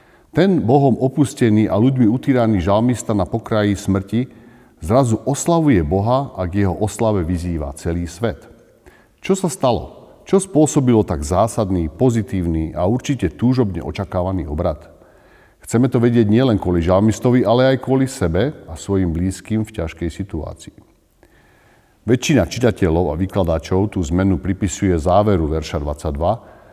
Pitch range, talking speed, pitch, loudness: 90-120 Hz, 130 wpm, 100 Hz, -18 LUFS